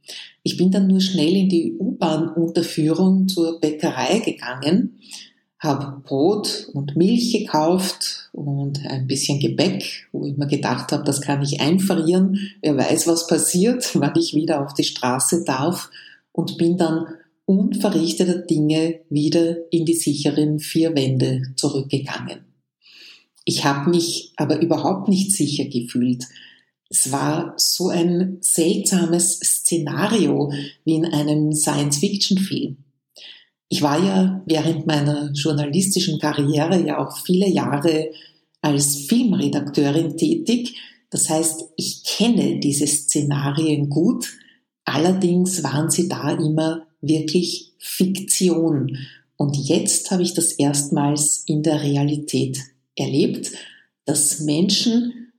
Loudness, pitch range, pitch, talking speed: -20 LUFS, 145-180 Hz, 160 Hz, 120 wpm